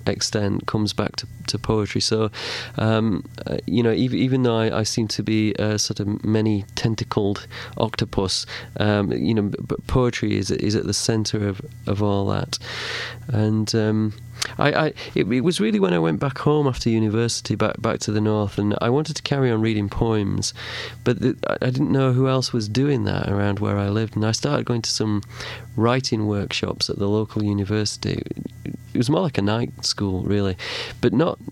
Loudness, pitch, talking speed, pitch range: -22 LUFS, 110 Hz, 195 wpm, 105-120 Hz